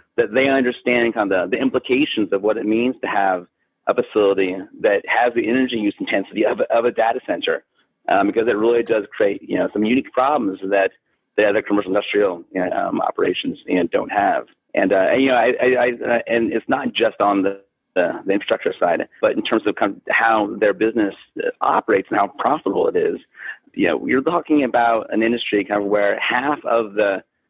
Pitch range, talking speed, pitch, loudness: 105-130 Hz, 205 wpm, 115 Hz, -19 LUFS